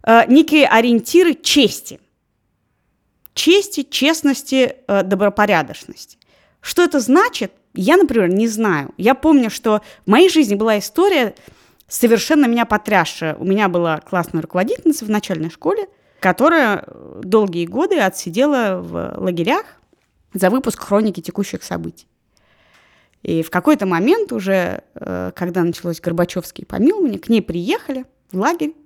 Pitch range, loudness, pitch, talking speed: 185-280 Hz, -16 LUFS, 215 Hz, 120 wpm